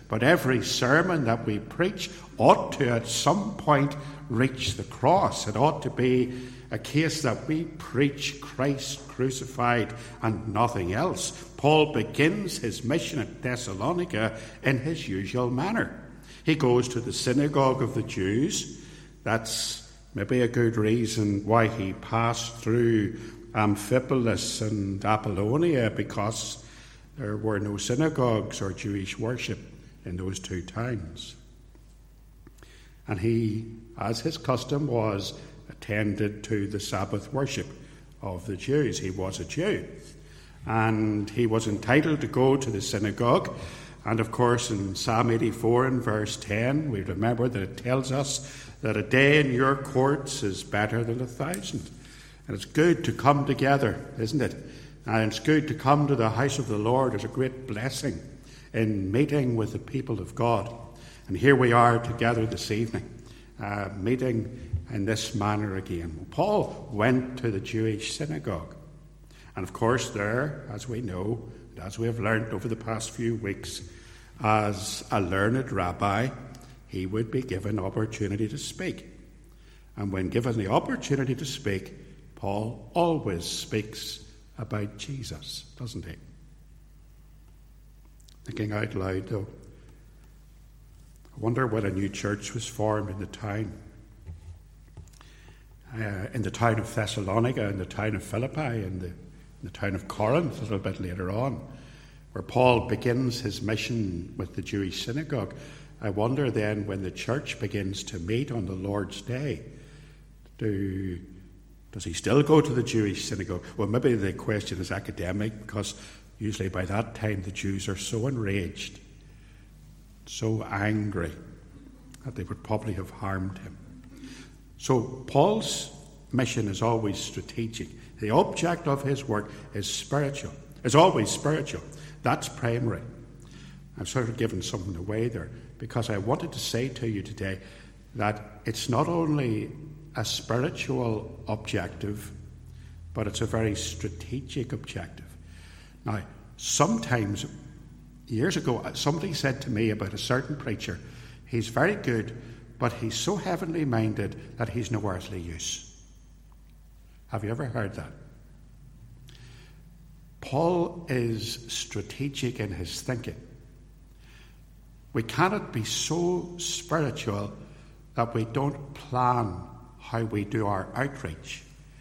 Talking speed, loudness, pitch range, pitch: 140 wpm, -28 LUFS, 105-135 Hz, 115 Hz